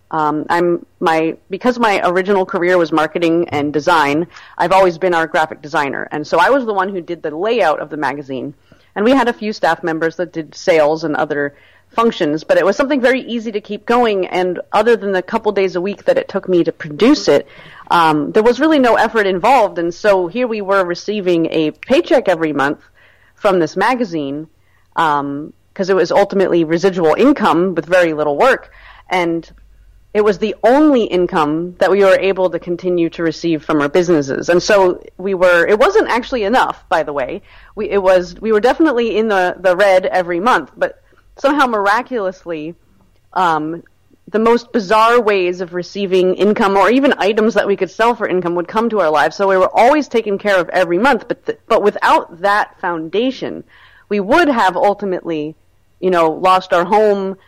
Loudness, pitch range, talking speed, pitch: -15 LUFS, 165-210 Hz, 195 wpm, 185 Hz